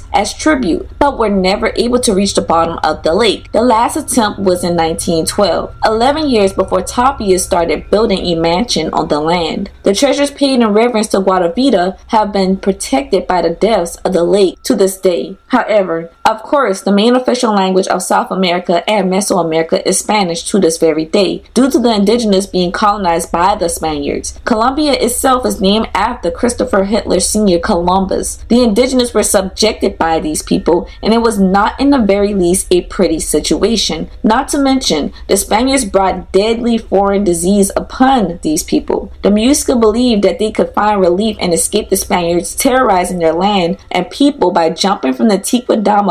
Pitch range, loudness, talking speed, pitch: 180-230 Hz, -12 LUFS, 180 wpm, 200 Hz